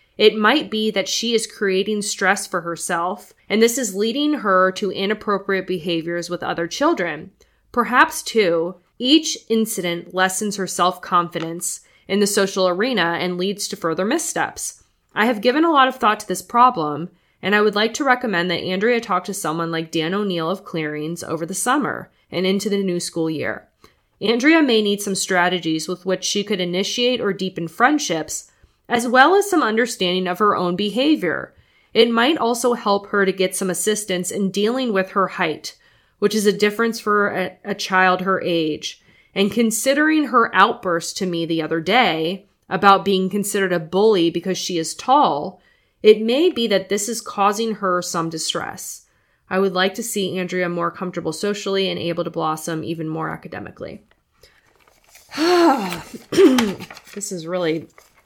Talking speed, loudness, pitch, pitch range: 170 wpm, -19 LUFS, 195 Hz, 175-220 Hz